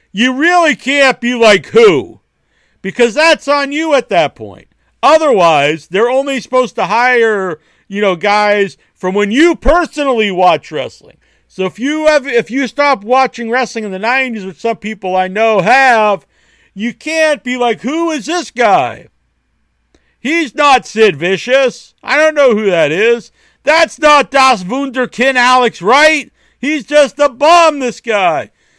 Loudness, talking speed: -11 LUFS, 160 wpm